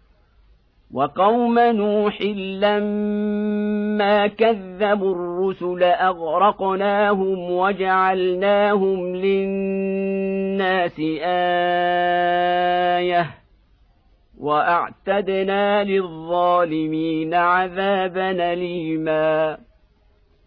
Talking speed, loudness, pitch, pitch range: 40 wpm, -20 LUFS, 190 Hz, 175-200 Hz